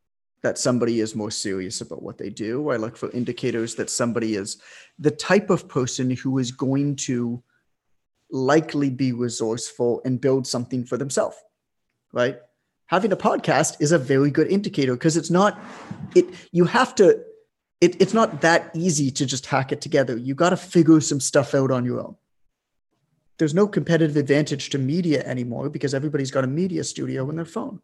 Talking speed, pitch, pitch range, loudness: 180 wpm, 140 Hz, 125-165 Hz, -22 LUFS